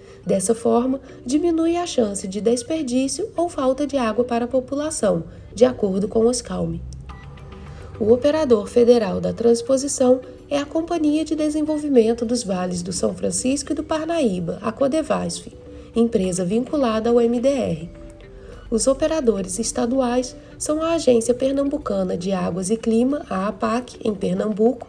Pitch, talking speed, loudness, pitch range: 245 Hz, 140 wpm, -21 LUFS, 220-285 Hz